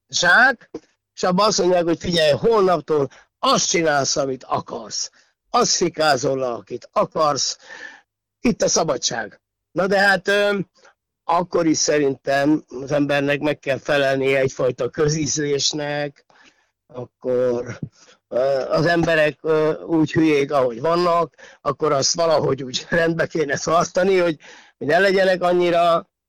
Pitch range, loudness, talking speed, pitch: 140-175 Hz, -19 LUFS, 115 wpm, 155 Hz